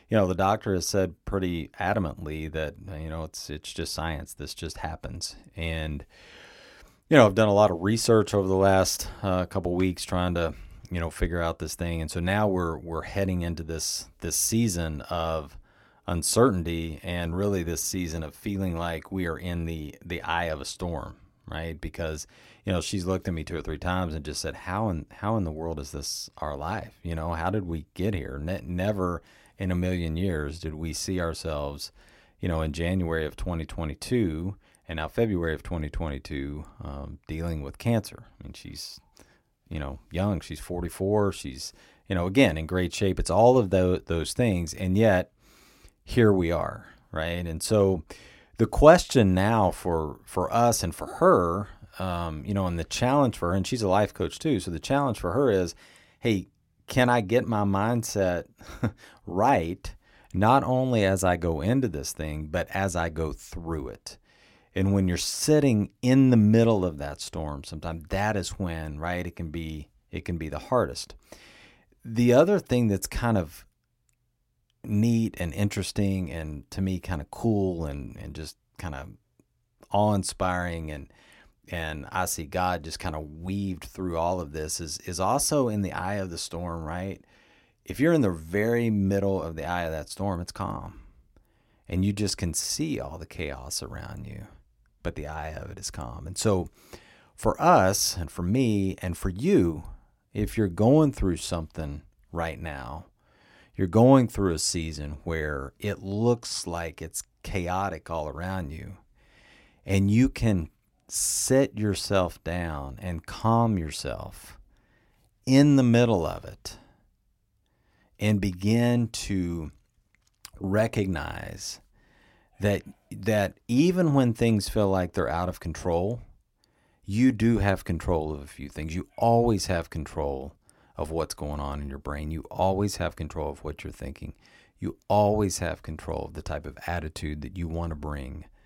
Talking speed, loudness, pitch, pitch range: 175 wpm, -27 LUFS, 90 Hz, 80-100 Hz